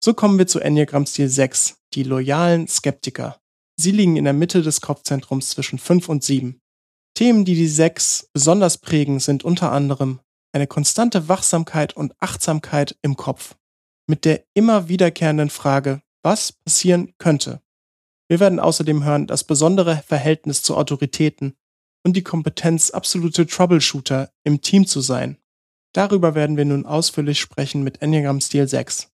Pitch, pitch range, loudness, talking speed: 150 Hz, 140-170 Hz, -18 LUFS, 150 wpm